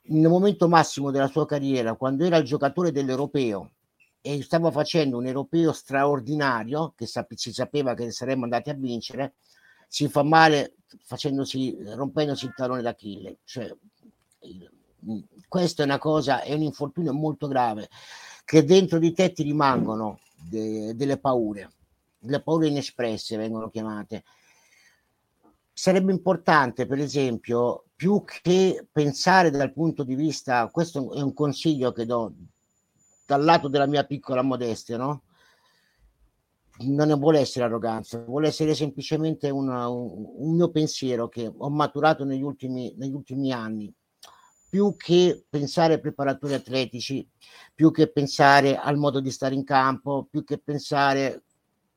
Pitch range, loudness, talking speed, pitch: 125-155 Hz, -24 LUFS, 135 wpm, 140 Hz